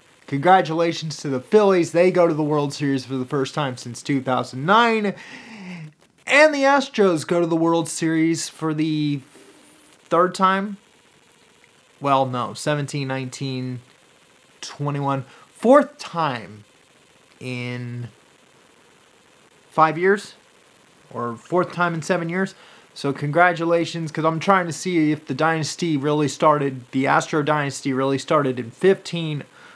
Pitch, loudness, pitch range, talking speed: 155 Hz, -21 LUFS, 135-175 Hz, 125 wpm